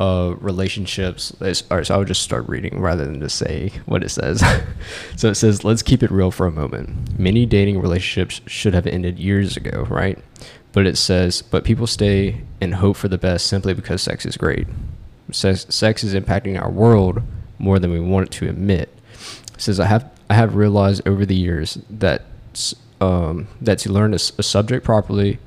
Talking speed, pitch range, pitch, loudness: 205 wpm, 95-110 Hz, 100 Hz, -19 LUFS